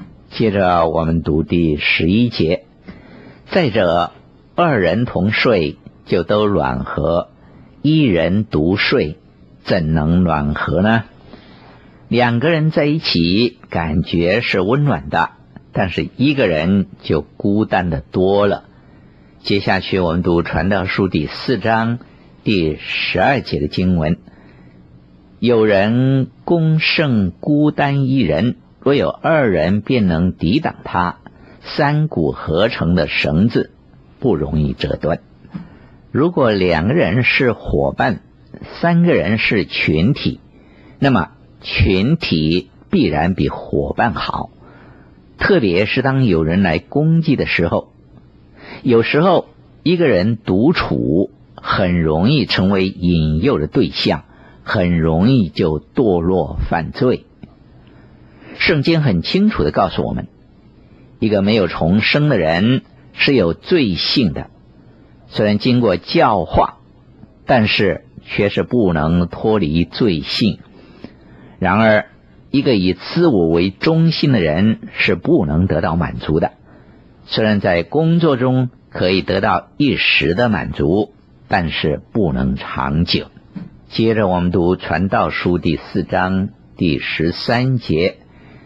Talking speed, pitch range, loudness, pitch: 175 characters per minute, 80-125 Hz, -16 LUFS, 95 Hz